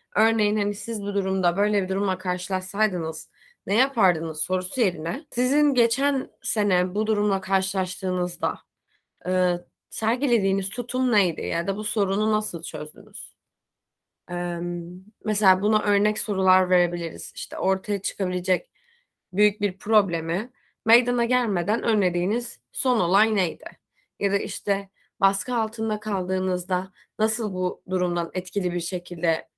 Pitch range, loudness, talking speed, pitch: 180-215 Hz, -24 LUFS, 120 wpm, 195 Hz